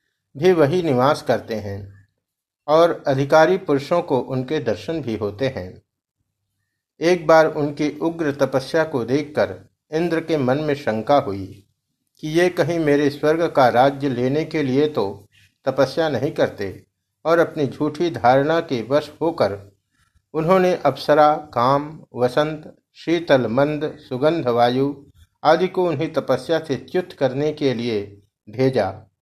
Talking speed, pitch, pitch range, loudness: 135 wpm, 140 Hz, 115-155 Hz, -20 LUFS